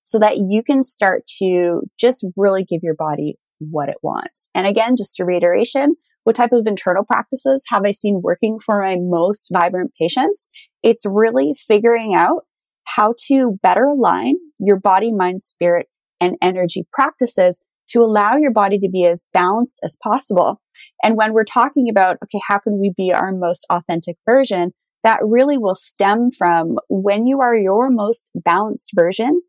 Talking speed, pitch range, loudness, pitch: 170 wpm, 180-240 Hz, -16 LUFS, 205 Hz